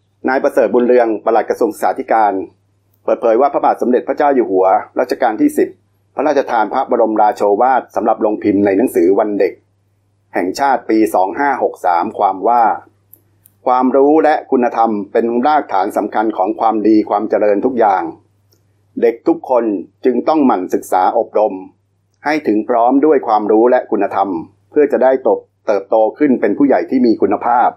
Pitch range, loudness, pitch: 100-135 Hz, -14 LUFS, 110 Hz